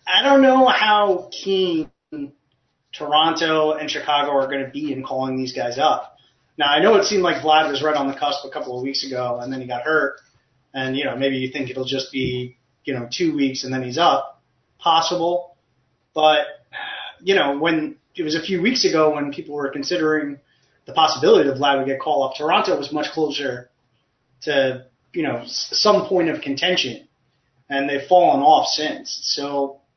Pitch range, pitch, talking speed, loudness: 135-165 Hz, 145 Hz, 190 wpm, -19 LUFS